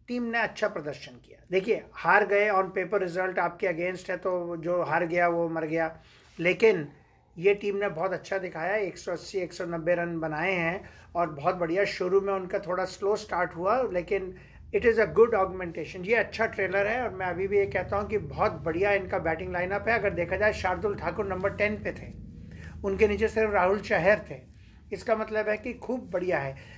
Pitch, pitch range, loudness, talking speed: 185 Hz, 175-205 Hz, -28 LUFS, 200 wpm